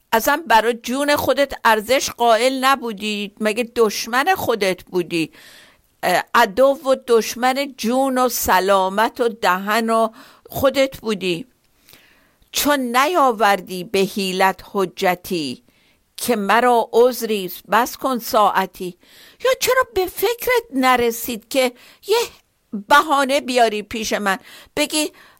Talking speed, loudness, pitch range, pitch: 105 wpm, -18 LUFS, 210-270 Hz, 235 Hz